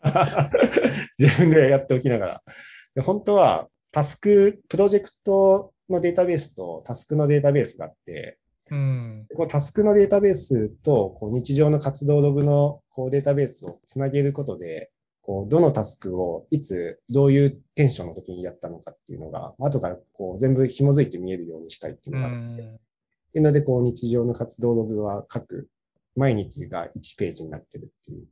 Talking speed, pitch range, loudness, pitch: 360 characters per minute, 120-150 Hz, -22 LUFS, 140 Hz